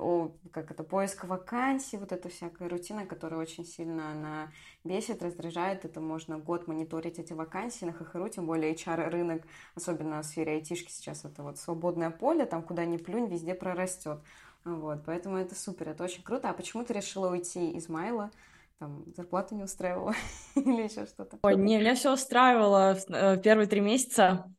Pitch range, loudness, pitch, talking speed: 165-195 Hz, -31 LUFS, 175 Hz, 170 wpm